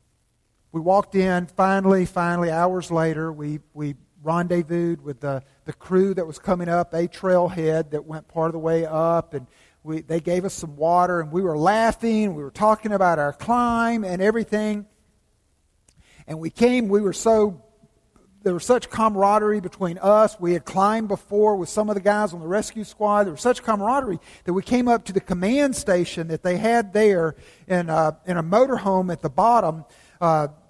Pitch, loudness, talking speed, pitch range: 180 Hz, -22 LUFS, 190 wpm, 160-210 Hz